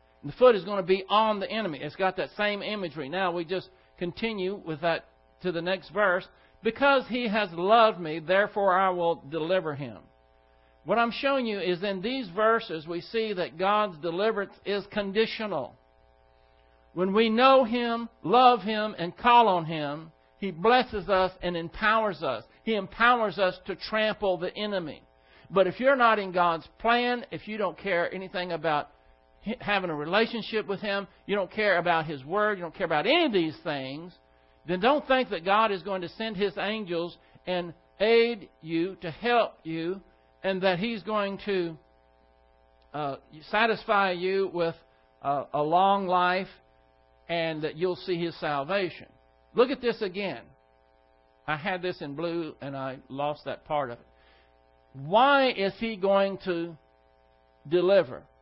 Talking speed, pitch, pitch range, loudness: 165 wpm, 185 Hz, 150-210 Hz, -27 LUFS